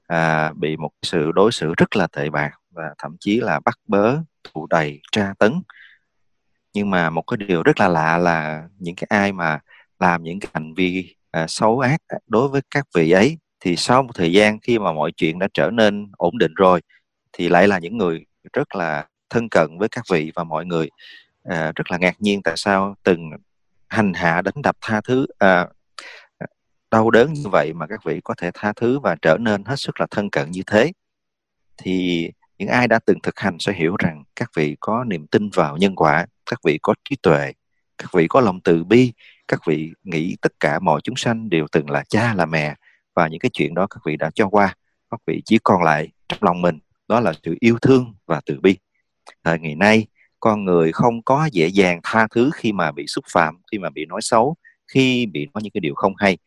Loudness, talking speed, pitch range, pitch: -19 LUFS, 225 wpm, 80-110 Hz, 95 Hz